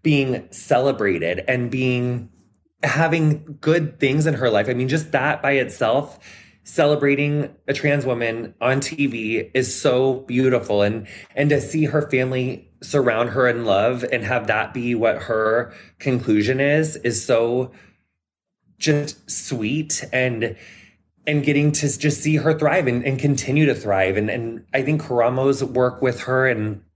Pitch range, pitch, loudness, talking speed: 115-145 Hz, 130 Hz, -20 LUFS, 155 wpm